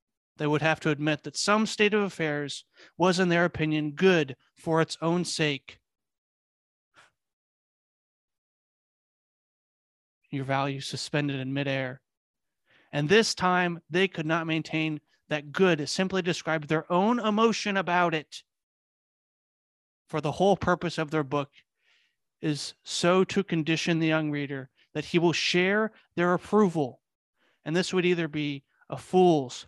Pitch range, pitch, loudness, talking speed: 150-185 Hz, 160 Hz, -27 LUFS, 135 wpm